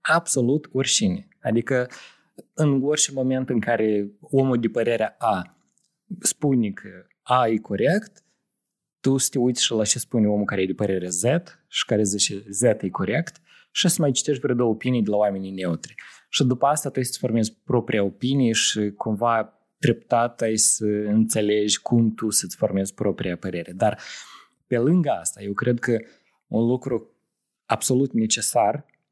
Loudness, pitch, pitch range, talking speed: -22 LUFS, 115 Hz, 105-135 Hz, 165 wpm